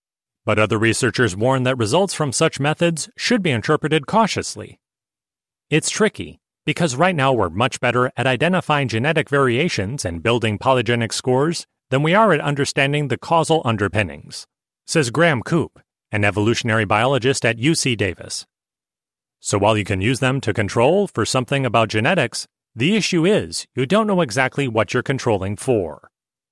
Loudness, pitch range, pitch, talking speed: -19 LUFS, 115-155 Hz, 130 Hz, 155 wpm